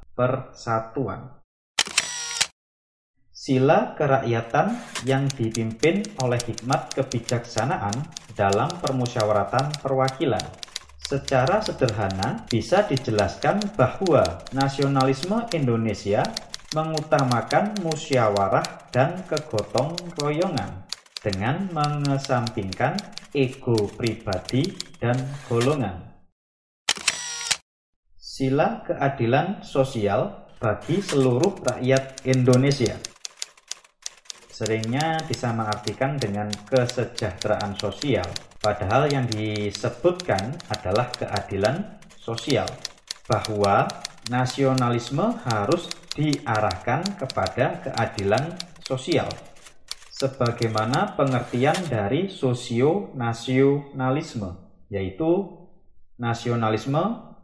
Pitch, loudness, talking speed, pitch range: 130 Hz, -24 LUFS, 65 wpm, 110-145 Hz